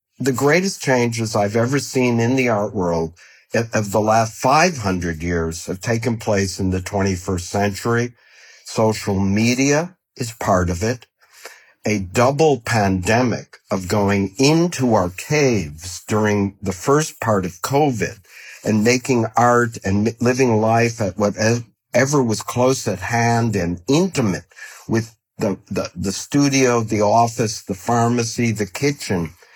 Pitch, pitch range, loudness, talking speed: 110 Hz, 100-125 Hz, -19 LUFS, 135 wpm